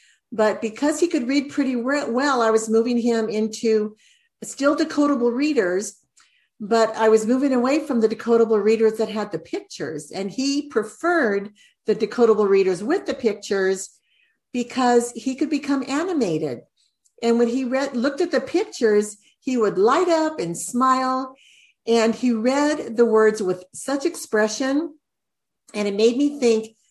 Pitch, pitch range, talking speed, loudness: 240 Hz, 220-280 Hz, 155 wpm, -21 LUFS